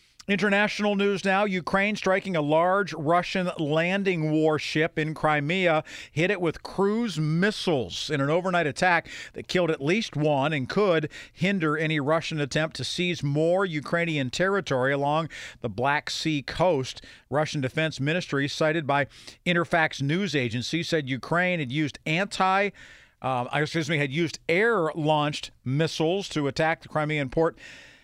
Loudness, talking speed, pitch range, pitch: -25 LUFS, 145 wpm, 145-180 Hz, 160 Hz